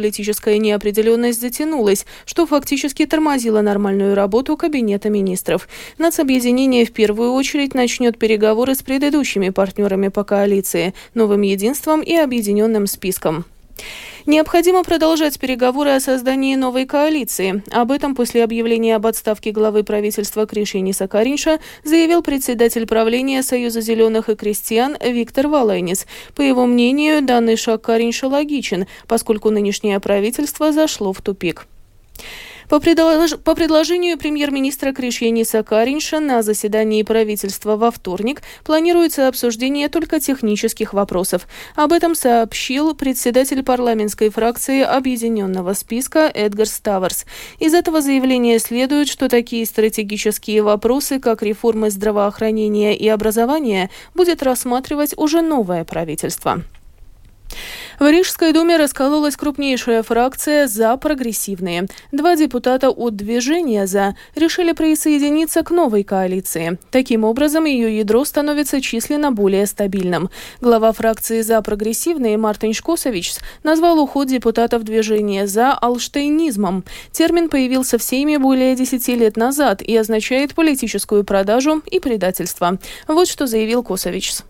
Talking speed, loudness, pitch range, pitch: 115 wpm, -16 LUFS, 215-290 Hz, 235 Hz